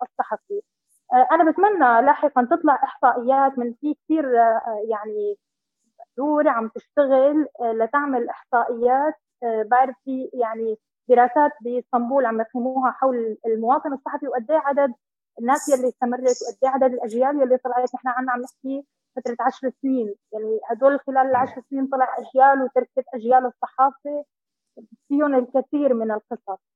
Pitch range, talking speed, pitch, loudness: 240-275 Hz, 130 wpm, 255 Hz, -21 LUFS